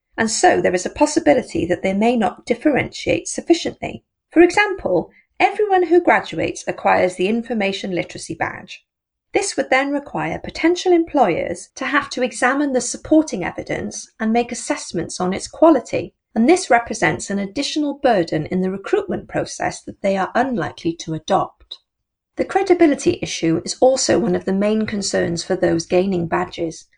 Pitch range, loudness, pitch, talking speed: 185-305 Hz, -19 LUFS, 245 Hz, 160 wpm